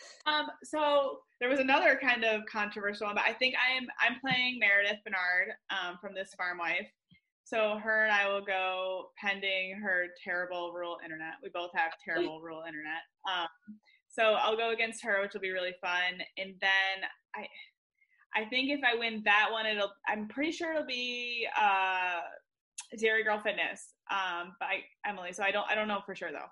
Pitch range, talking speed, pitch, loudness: 185-245 Hz, 185 wpm, 205 Hz, -31 LUFS